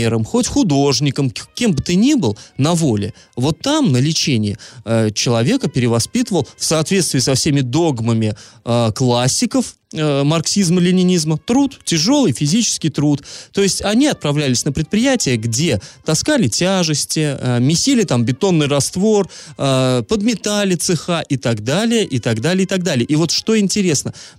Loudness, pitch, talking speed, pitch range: -16 LUFS, 155 Hz, 145 wpm, 125-195 Hz